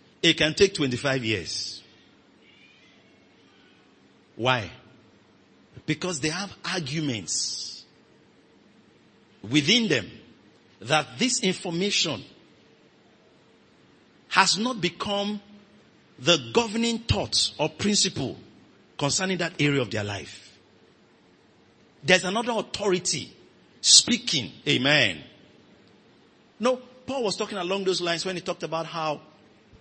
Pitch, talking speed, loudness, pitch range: 165 Hz, 95 wpm, -24 LUFS, 130-195 Hz